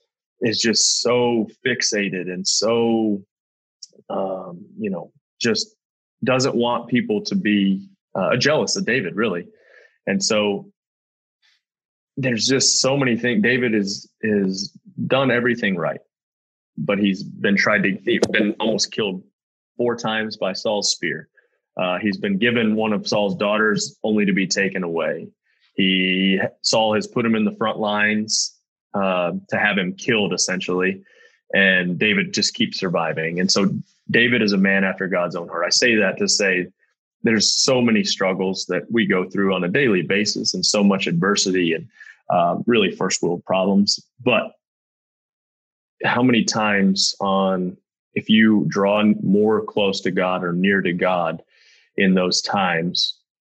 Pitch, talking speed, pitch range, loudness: 100 Hz, 155 wpm, 95-120 Hz, -19 LUFS